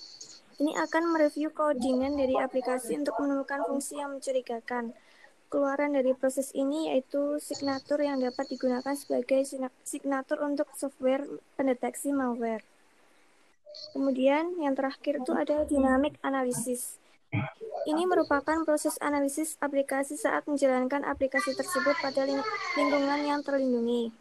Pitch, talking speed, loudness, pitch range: 280 Hz, 120 wpm, -29 LUFS, 265-295 Hz